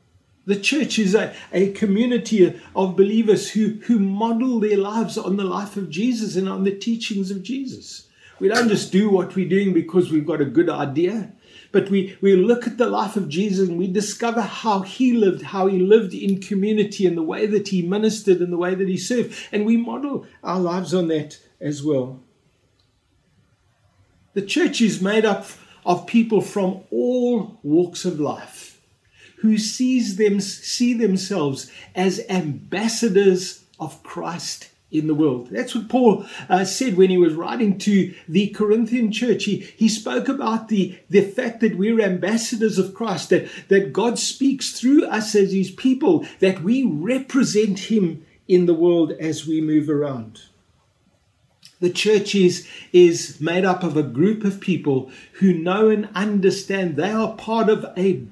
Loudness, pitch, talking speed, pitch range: -20 LUFS, 195 Hz, 170 wpm, 180-220 Hz